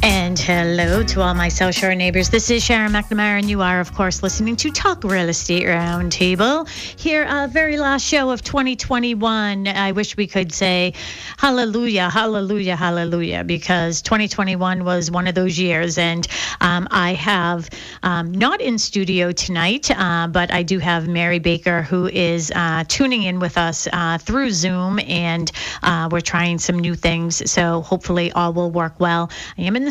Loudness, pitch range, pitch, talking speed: -18 LUFS, 175-210 Hz, 180 Hz, 175 wpm